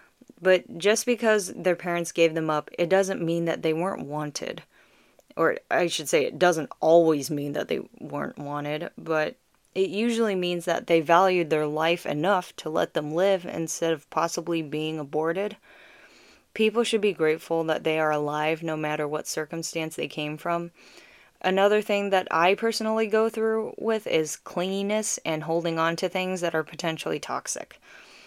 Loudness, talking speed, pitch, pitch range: -26 LUFS, 170 wpm, 170 Hz, 155-195 Hz